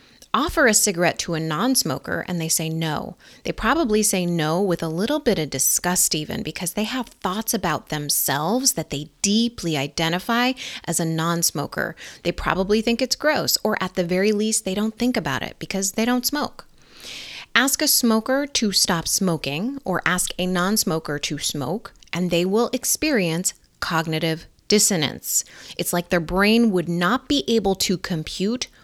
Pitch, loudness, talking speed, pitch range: 190 Hz, -21 LUFS, 175 wpm, 165-230 Hz